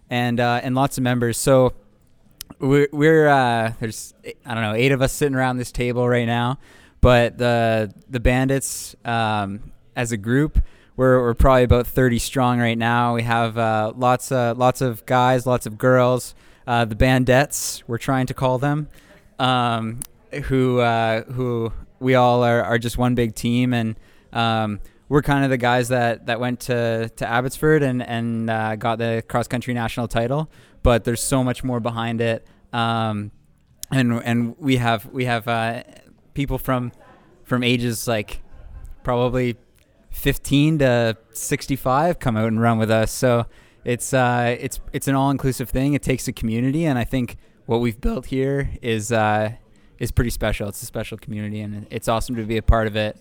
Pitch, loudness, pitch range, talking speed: 120 Hz, -21 LUFS, 115-130 Hz, 180 wpm